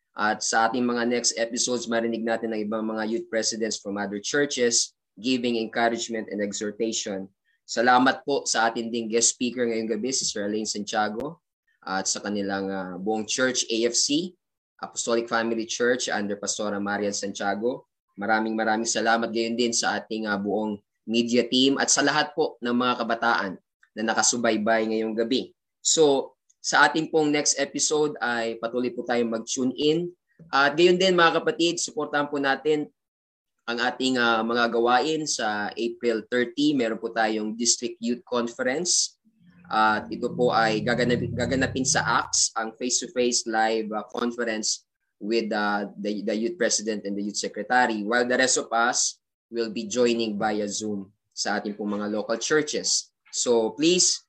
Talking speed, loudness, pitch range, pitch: 160 wpm, -24 LUFS, 110-125 Hz, 115 Hz